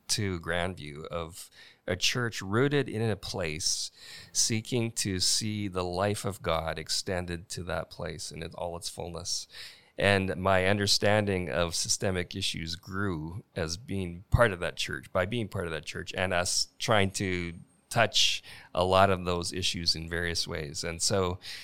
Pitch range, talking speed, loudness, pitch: 85-100 Hz, 165 wpm, -29 LUFS, 90 Hz